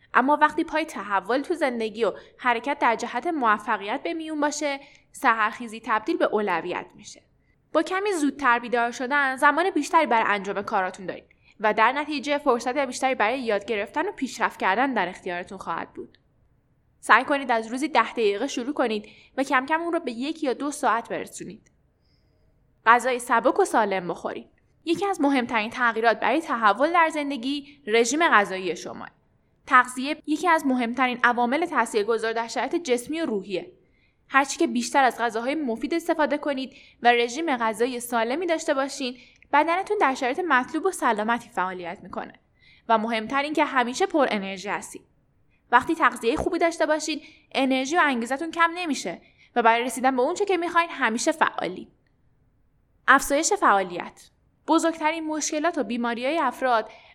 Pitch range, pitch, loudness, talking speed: 230-305 Hz, 260 Hz, -24 LUFS, 155 wpm